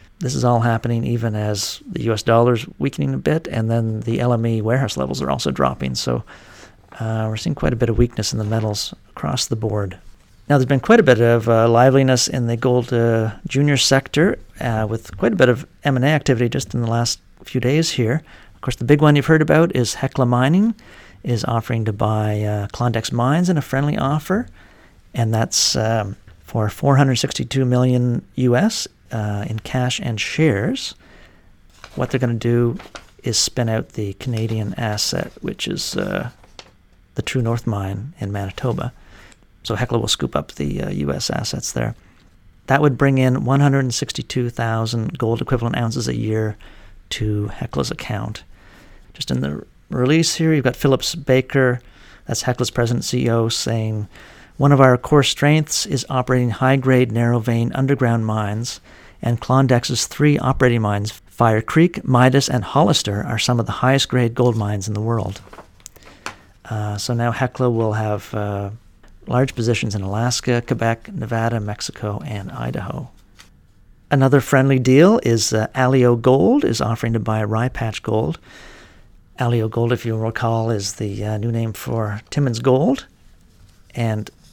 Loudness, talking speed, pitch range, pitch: -19 LUFS, 165 wpm, 105-130 Hz, 115 Hz